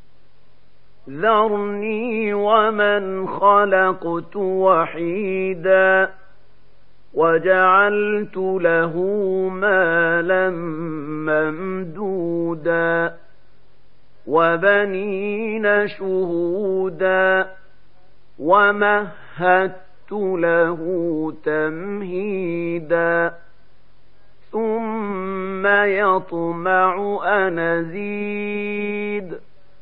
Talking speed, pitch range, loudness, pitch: 30 wpm, 170-205 Hz, -19 LUFS, 190 Hz